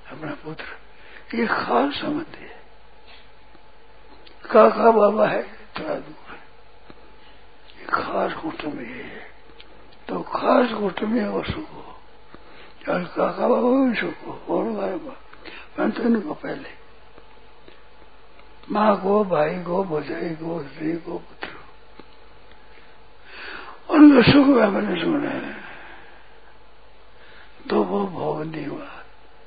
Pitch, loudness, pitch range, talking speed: 220 Hz, -21 LUFS, 175-280 Hz, 105 wpm